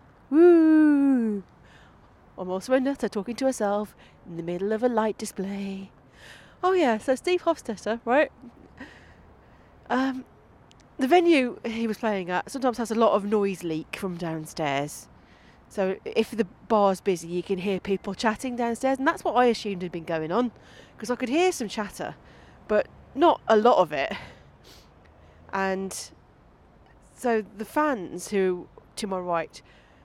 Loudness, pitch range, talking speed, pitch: -25 LUFS, 190-260 Hz, 155 wpm, 220 Hz